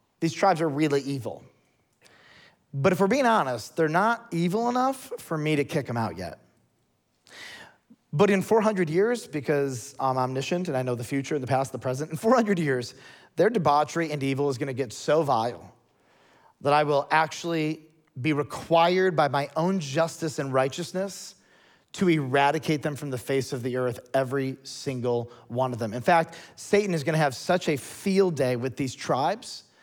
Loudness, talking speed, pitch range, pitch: -26 LUFS, 180 wpm, 135-170 Hz, 150 Hz